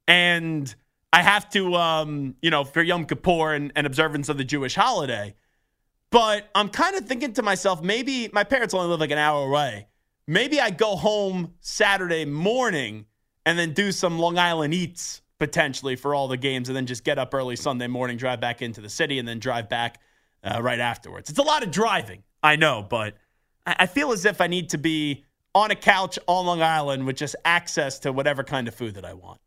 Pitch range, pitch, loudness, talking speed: 130-185 Hz, 155 Hz, -23 LUFS, 210 wpm